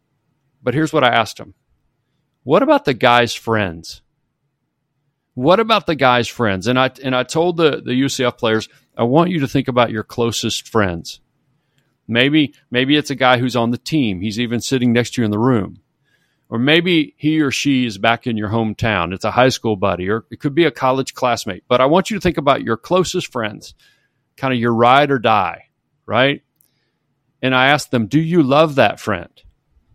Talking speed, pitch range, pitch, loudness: 200 wpm, 115-145 Hz, 130 Hz, -16 LUFS